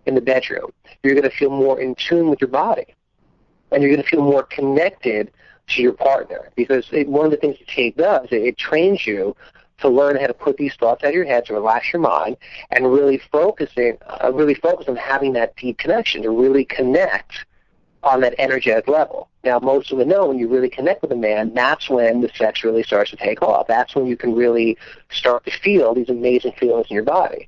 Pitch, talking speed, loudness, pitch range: 135 Hz, 225 wpm, -18 LUFS, 120-145 Hz